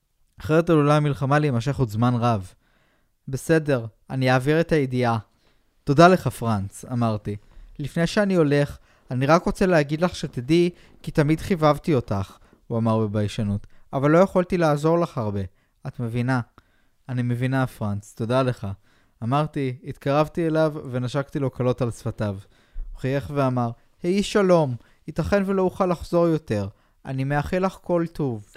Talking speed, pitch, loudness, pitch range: 145 wpm, 135 Hz, -23 LUFS, 115-160 Hz